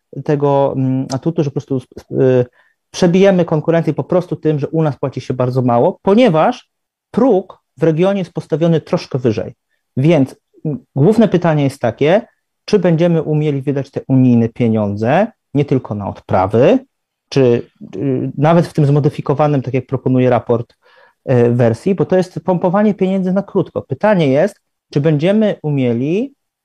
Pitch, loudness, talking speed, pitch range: 150 Hz, -15 LUFS, 145 wpm, 130-180 Hz